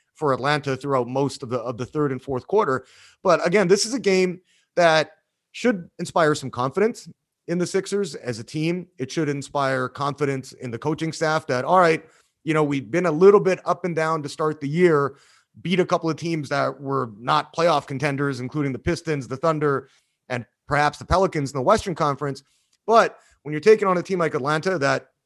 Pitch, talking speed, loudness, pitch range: 150 Hz, 205 wpm, -22 LUFS, 135-175 Hz